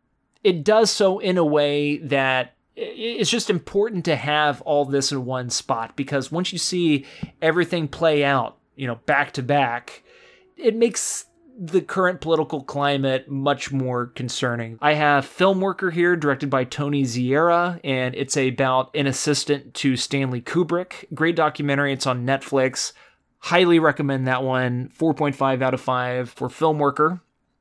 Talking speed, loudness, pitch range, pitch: 150 wpm, -21 LUFS, 135-175 Hz, 145 Hz